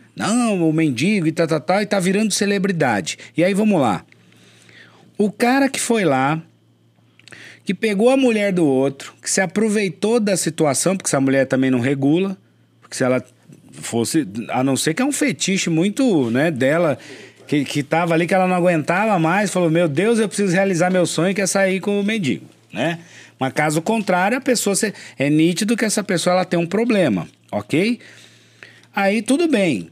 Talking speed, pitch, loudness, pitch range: 190 wpm, 180 Hz, -18 LUFS, 150-210 Hz